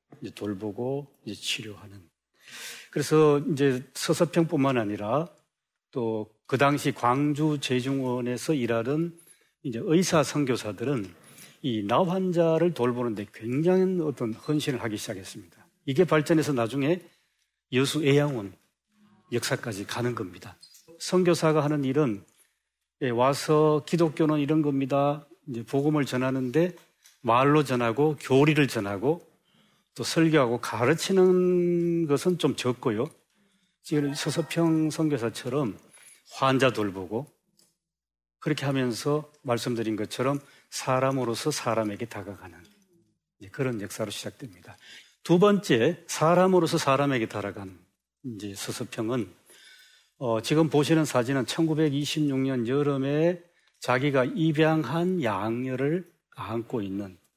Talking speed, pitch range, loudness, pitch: 250 characters per minute, 115-160 Hz, -26 LUFS, 140 Hz